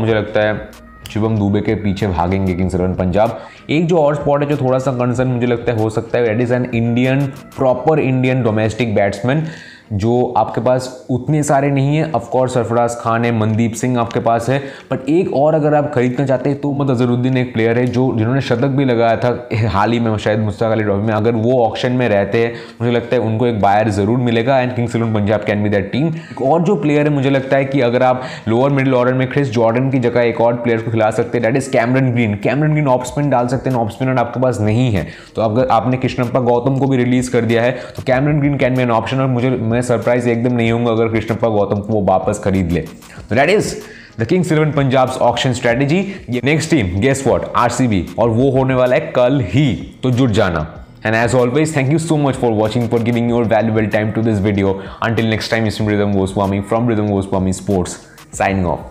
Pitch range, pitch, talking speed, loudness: 110-130 Hz, 120 Hz, 220 wpm, -15 LUFS